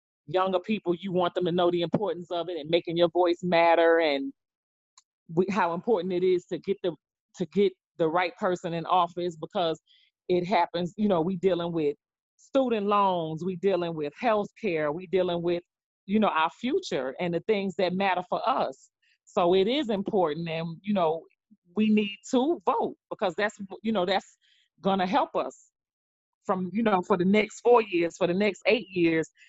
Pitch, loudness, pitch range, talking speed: 180 Hz, -27 LUFS, 170-205 Hz, 190 wpm